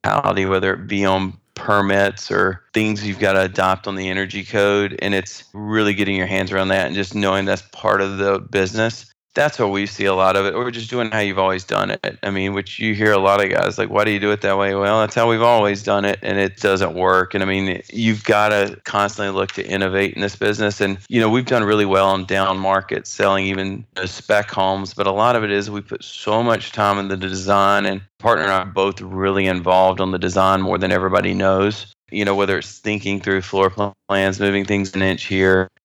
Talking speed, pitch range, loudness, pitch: 240 wpm, 95-105 Hz, -18 LUFS, 100 Hz